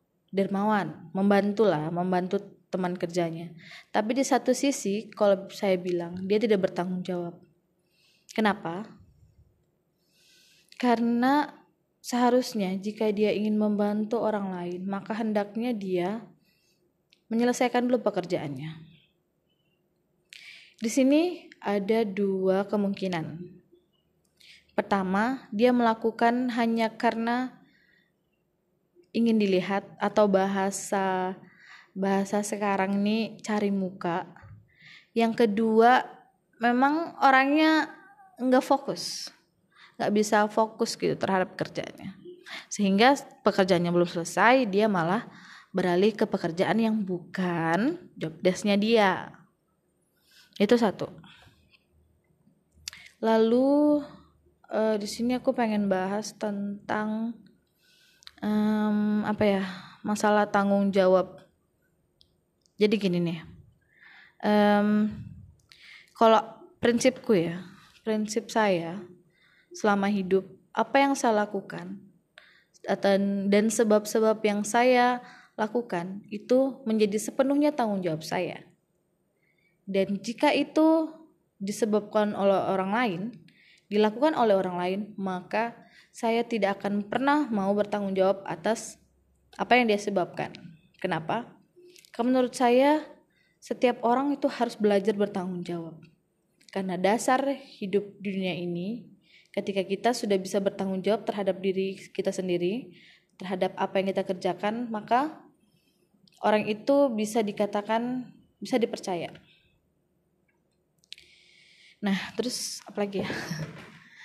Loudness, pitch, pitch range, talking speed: -26 LUFS, 205 Hz, 185-230 Hz, 100 wpm